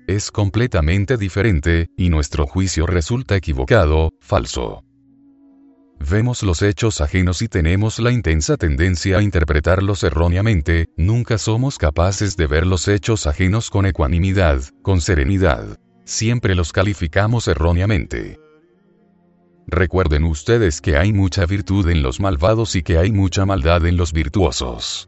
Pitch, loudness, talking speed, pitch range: 95 Hz, -18 LUFS, 130 wpm, 85-110 Hz